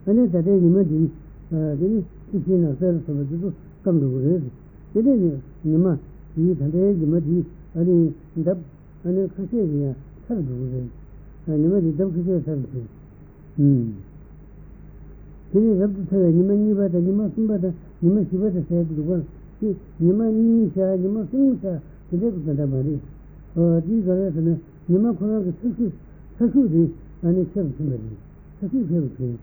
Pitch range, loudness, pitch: 155-195 Hz, -22 LUFS, 175 Hz